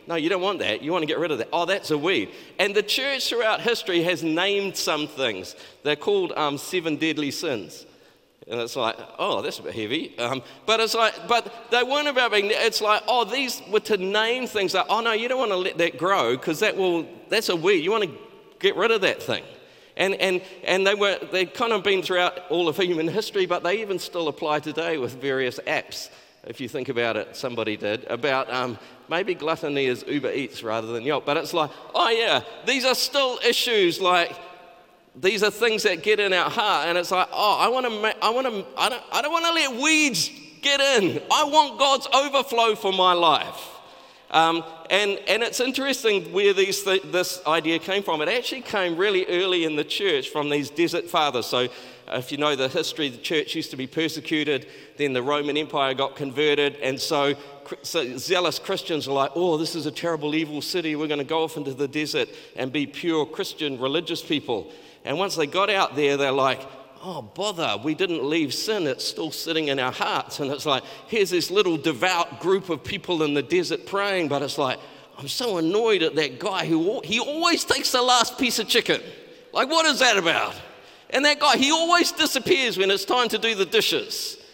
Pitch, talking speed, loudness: 185 Hz, 215 wpm, -23 LUFS